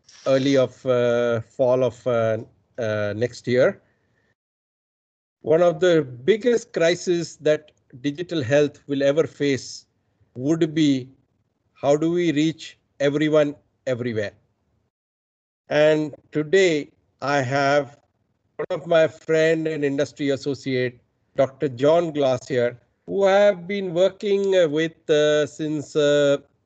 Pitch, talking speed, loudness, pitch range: 145 Hz, 115 wpm, -22 LUFS, 125-160 Hz